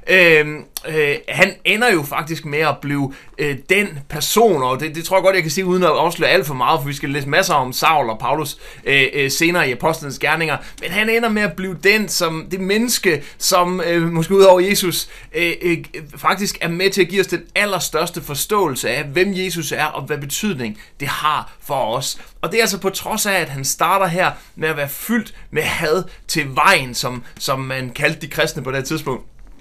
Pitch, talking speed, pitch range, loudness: 165 Hz, 220 wpm, 150-190 Hz, -17 LUFS